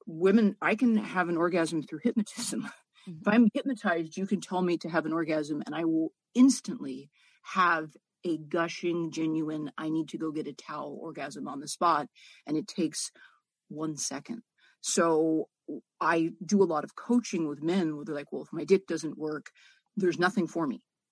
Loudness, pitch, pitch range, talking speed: -30 LUFS, 170 Hz, 160-210 Hz, 185 wpm